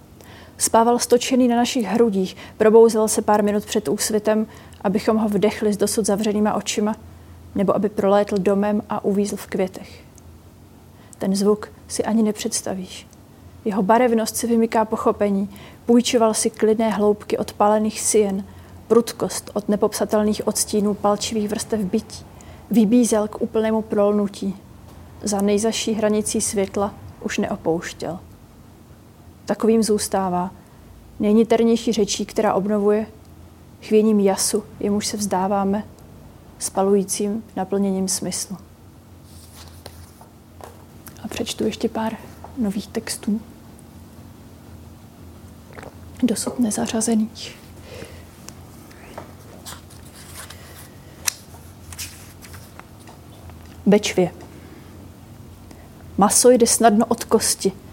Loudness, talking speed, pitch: -20 LUFS, 90 wpm, 205 Hz